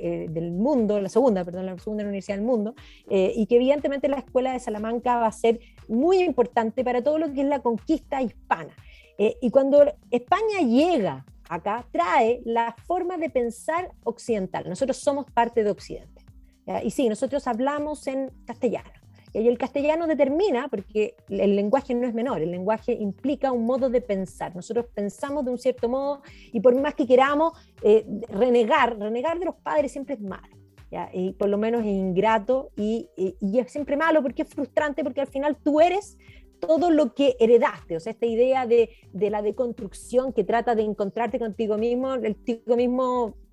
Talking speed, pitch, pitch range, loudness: 180 wpm, 240 Hz, 215-280 Hz, -24 LUFS